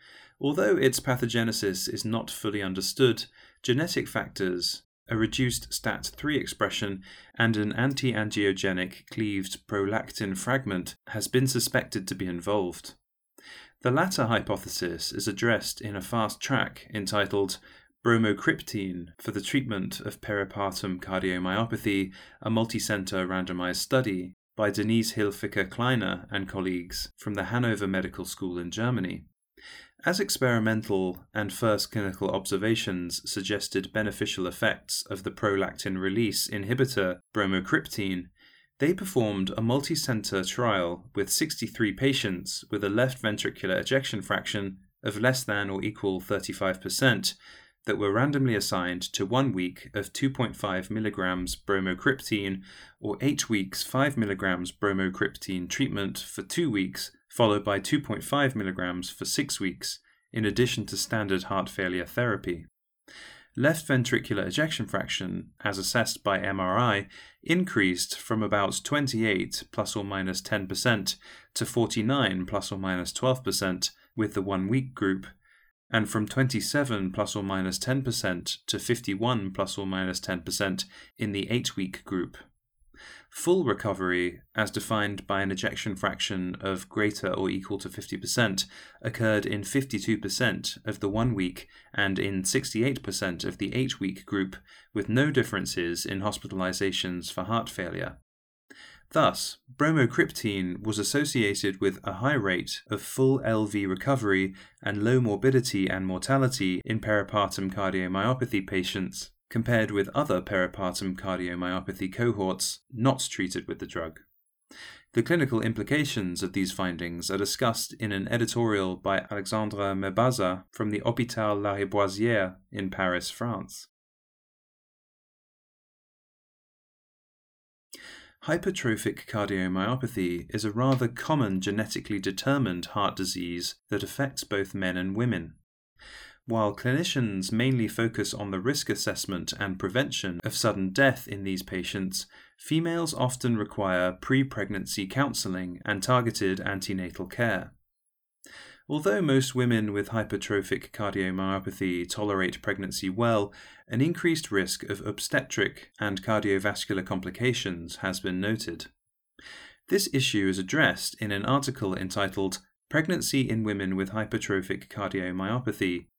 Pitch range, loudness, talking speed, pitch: 95-115 Hz, -28 LUFS, 125 wpm, 100 Hz